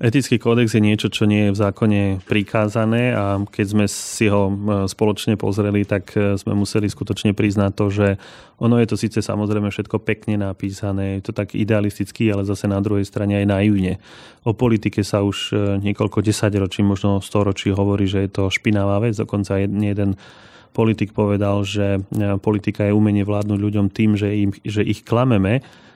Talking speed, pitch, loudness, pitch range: 170 wpm, 105 Hz, -19 LUFS, 100-110 Hz